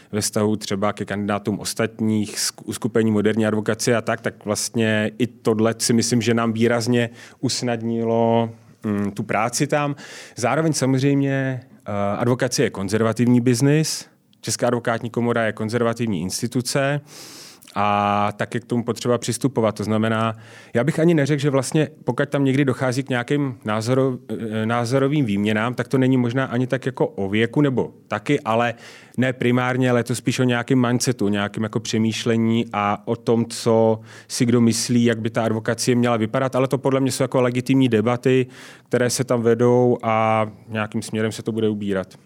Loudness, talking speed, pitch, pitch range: -21 LUFS, 160 wpm, 120 Hz, 110-130 Hz